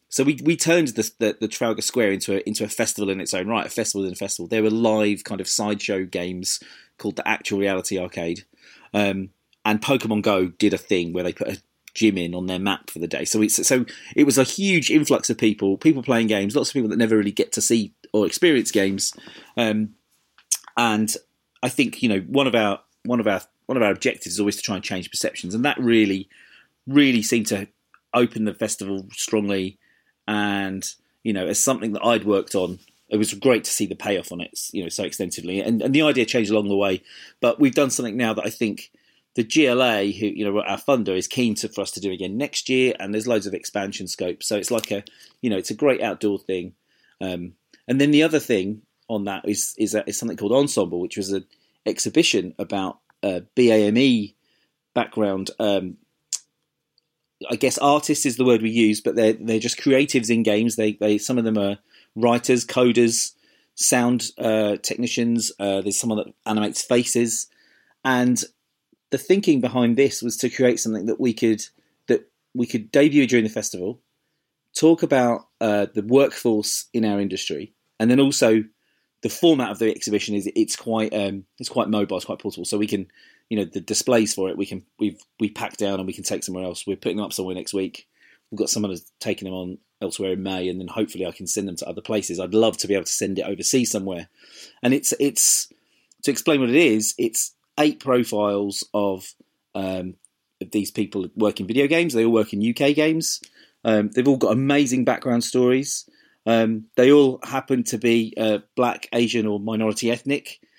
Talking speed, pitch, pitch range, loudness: 210 wpm, 110 Hz, 100-120 Hz, -22 LUFS